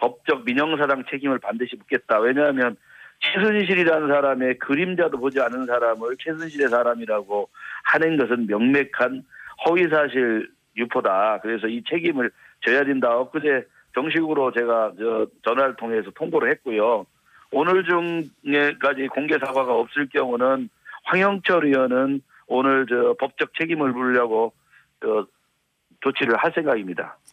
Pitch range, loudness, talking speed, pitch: 120-155 Hz, -22 LUFS, 295 characters per minute, 135 Hz